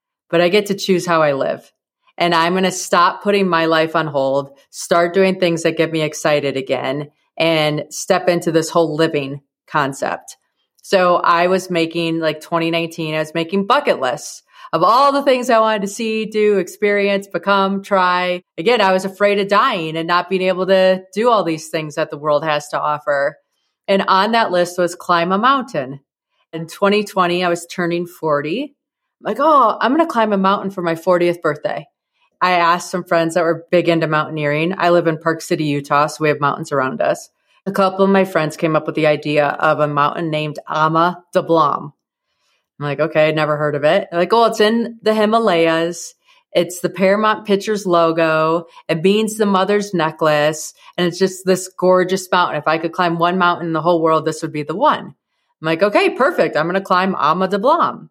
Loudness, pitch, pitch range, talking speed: -16 LUFS, 175 Hz, 155-195 Hz, 205 wpm